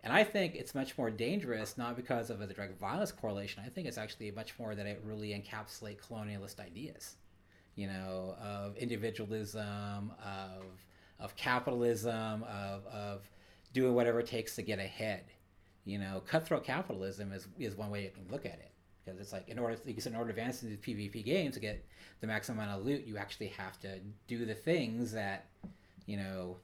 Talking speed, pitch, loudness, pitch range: 195 wpm, 105 Hz, -39 LUFS, 95-115 Hz